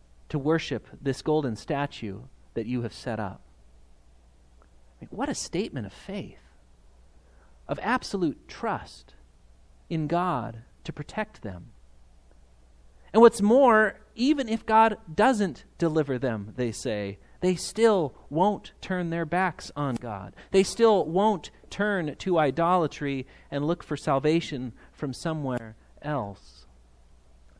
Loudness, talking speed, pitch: -27 LUFS, 120 wpm, 130 Hz